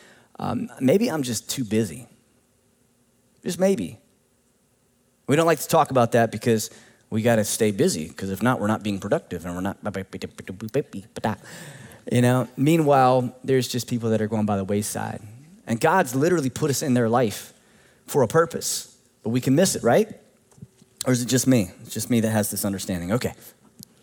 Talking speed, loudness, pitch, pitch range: 180 wpm, -23 LUFS, 120 Hz, 110-130 Hz